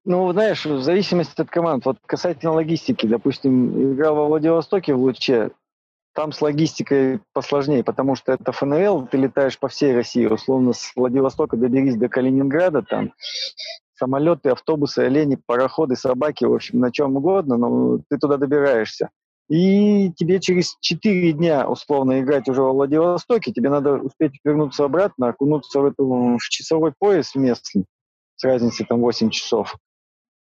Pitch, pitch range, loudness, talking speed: 140 Hz, 130-160 Hz, -19 LUFS, 150 wpm